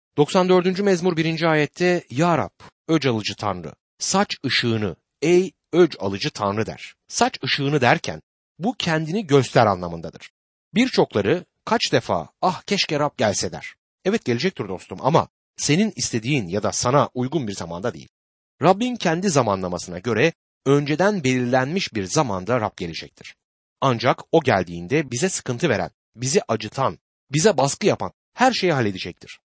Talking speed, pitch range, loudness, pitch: 140 wpm, 105-170 Hz, -21 LUFS, 140 Hz